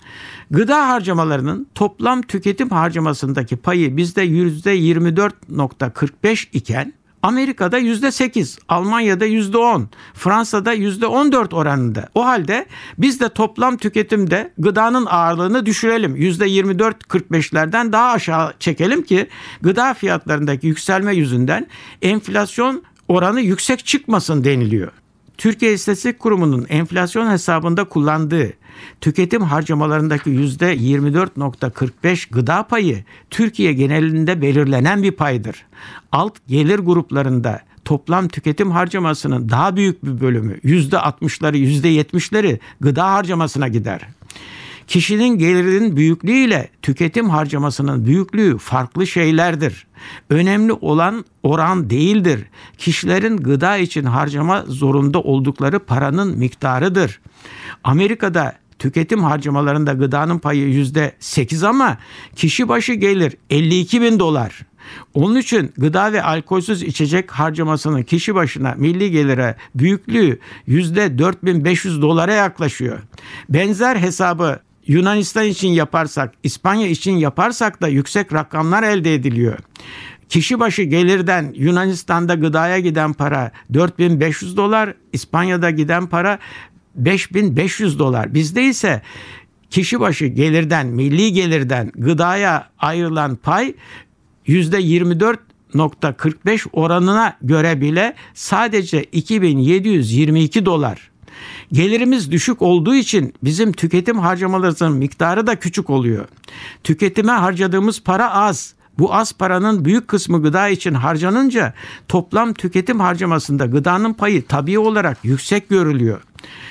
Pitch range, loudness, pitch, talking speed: 145-200 Hz, -16 LUFS, 170 Hz, 100 wpm